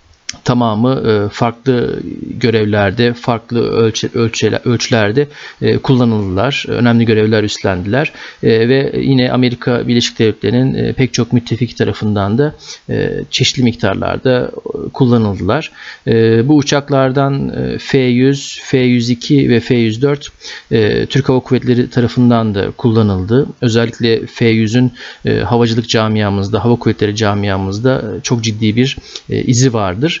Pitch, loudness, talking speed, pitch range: 120 Hz, -13 LUFS, 95 wpm, 110-130 Hz